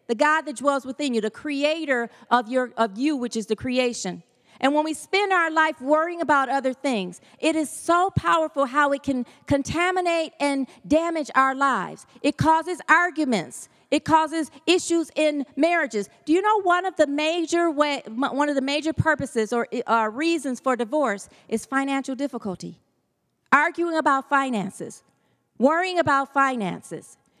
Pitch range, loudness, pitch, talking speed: 255-315 Hz, -23 LUFS, 285 Hz, 160 wpm